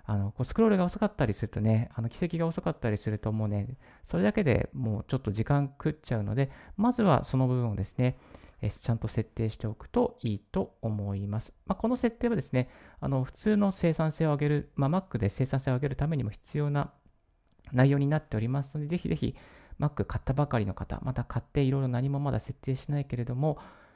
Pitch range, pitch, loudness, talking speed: 110-150 Hz, 130 Hz, -30 LUFS, 435 characters per minute